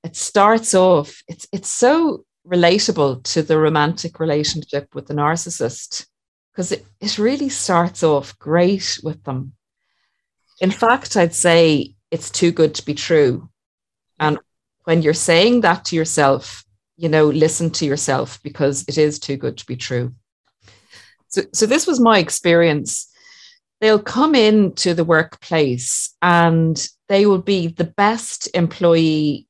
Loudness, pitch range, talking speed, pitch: -17 LUFS, 150-190 Hz, 145 wpm, 165 Hz